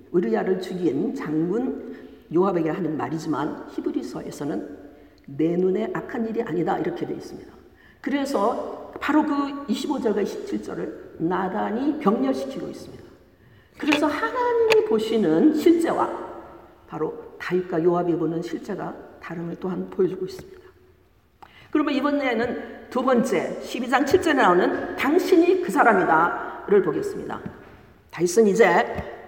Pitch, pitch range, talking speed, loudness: 250 Hz, 185-315 Hz, 285 characters per minute, -23 LUFS